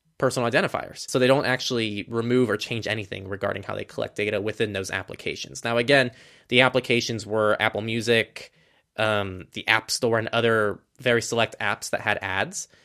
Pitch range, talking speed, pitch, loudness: 105-125 Hz, 175 wpm, 115 Hz, -24 LUFS